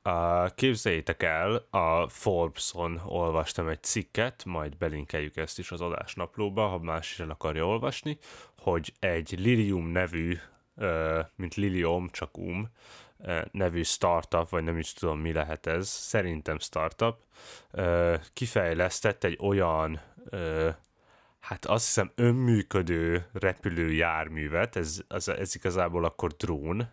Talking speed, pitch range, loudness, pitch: 115 wpm, 80-100 Hz, -30 LUFS, 85 Hz